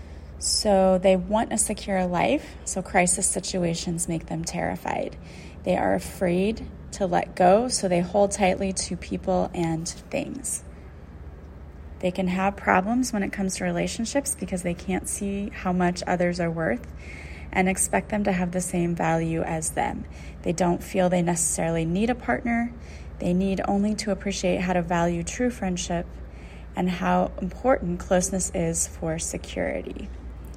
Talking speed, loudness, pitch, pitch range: 155 wpm, -25 LUFS, 180 Hz, 165-195 Hz